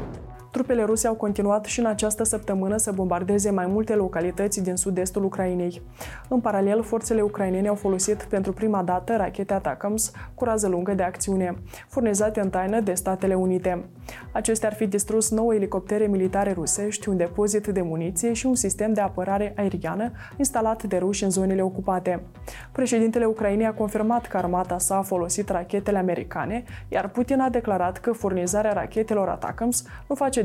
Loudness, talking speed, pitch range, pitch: -24 LUFS, 165 wpm, 185-220 Hz, 205 Hz